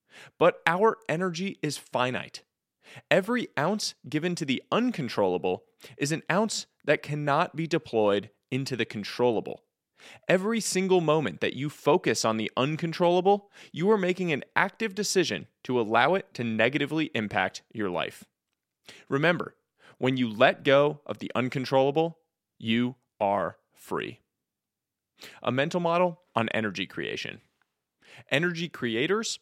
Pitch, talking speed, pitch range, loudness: 150 Hz, 130 wpm, 125-185 Hz, -27 LUFS